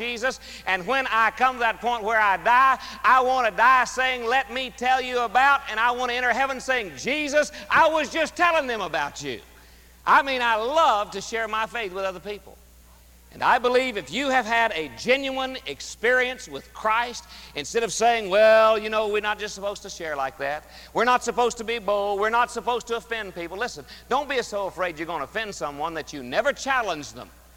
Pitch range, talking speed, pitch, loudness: 195-255 Hz, 220 wpm, 230 Hz, -23 LUFS